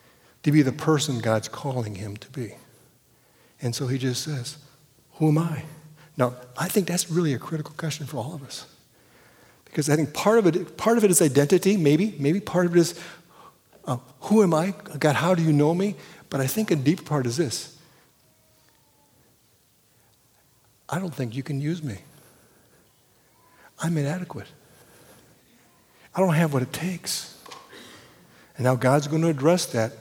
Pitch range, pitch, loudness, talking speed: 130-170 Hz, 150 Hz, -24 LUFS, 170 wpm